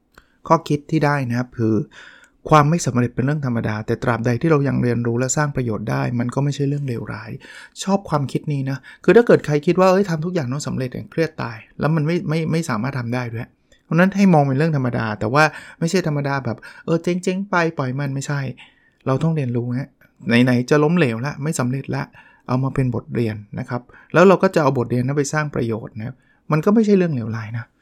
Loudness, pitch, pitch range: -19 LUFS, 140 Hz, 120-160 Hz